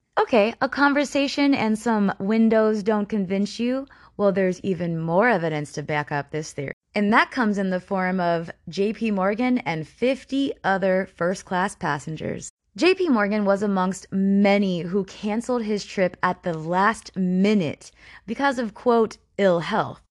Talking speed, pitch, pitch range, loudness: 160 wpm, 200 Hz, 180-225 Hz, -23 LUFS